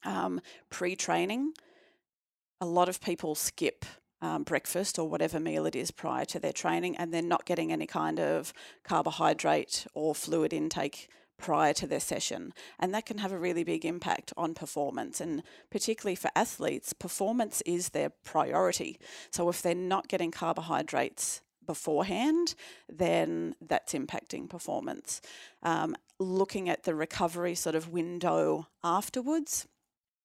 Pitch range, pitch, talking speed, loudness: 165-195 Hz, 175 Hz, 145 wpm, -32 LUFS